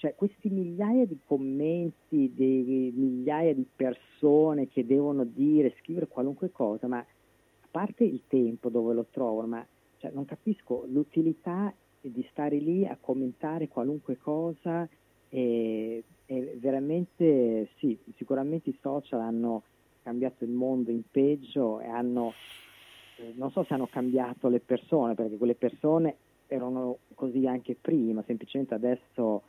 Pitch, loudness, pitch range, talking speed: 130 Hz, -30 LUFS, 120-150 Hz, 135 wpm